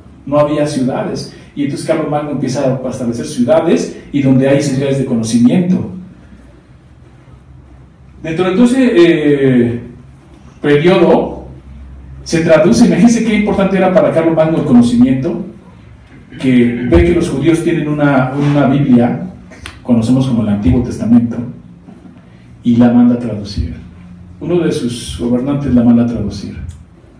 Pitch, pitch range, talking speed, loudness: 130 Hz, 105-155 Hz, 130 wpm, -12 LUFS